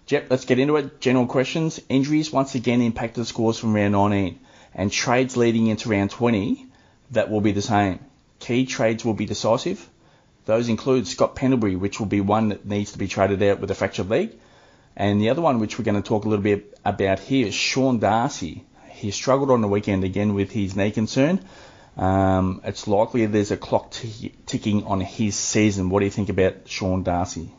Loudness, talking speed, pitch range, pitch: -22 LUFS, 205 wpm, 100-125 Hz, 110 Hz